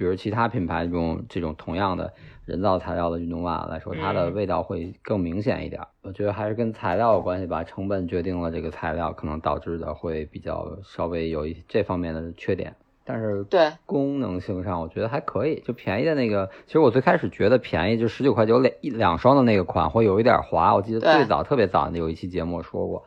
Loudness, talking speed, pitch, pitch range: -24 LUFS, 350 characters per minute, 90 Hz, 85-105 Hz